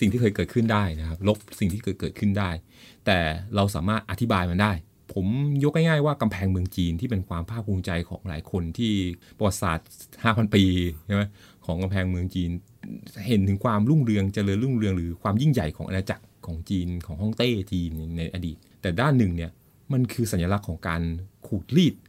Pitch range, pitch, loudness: 90-110 Hz, 100 Hz, -26 LUFS